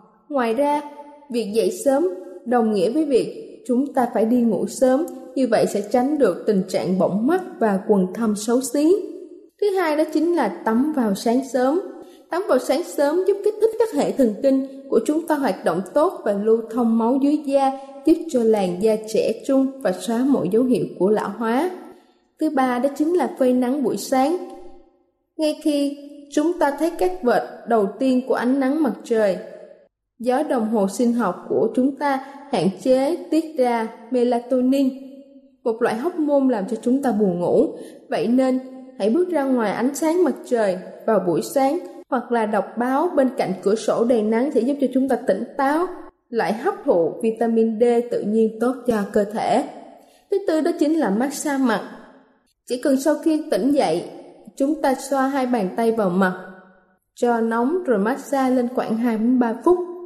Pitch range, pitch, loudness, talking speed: 230-295 Hz, 260 Hz, -21 LUFS, 190 wpm